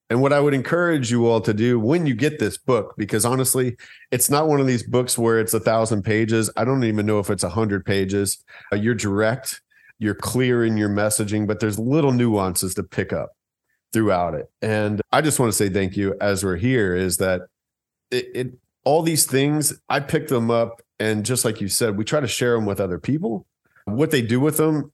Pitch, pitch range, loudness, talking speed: 115 Hz, 105-130 Hz, -21 LUFS, 220 wpm